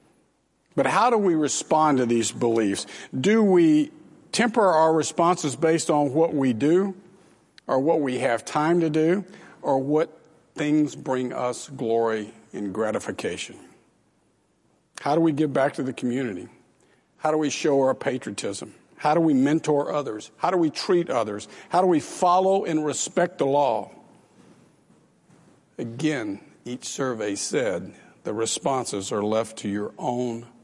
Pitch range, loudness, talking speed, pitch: 125-165 Hz, -24 LUFS, 150 wpm, 150 Hz